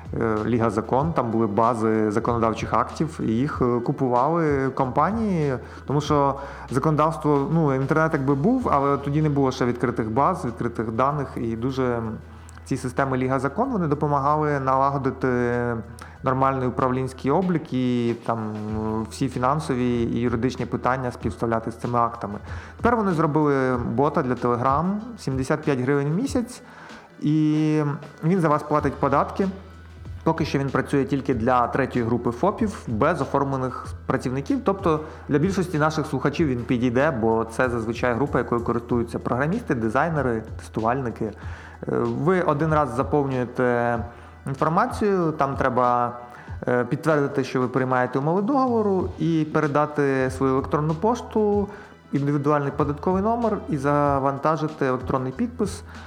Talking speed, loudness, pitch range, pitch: 125 wpm, -23 LUFS, 120-150 Hz, 135 Hz